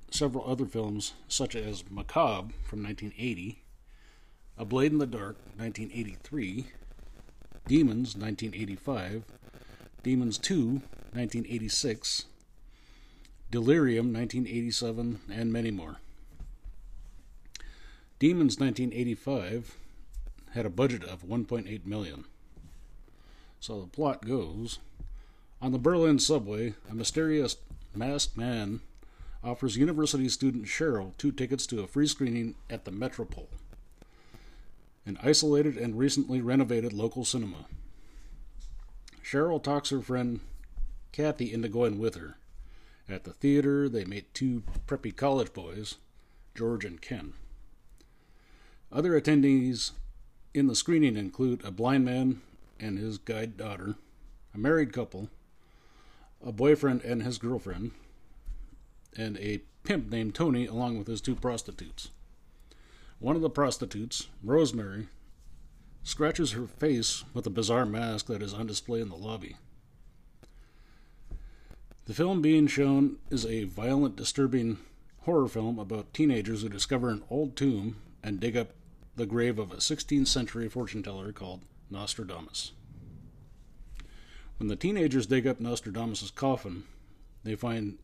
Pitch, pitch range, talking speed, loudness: 115 Hz, 105-130 Hz, 120 wpm, -30 LUFS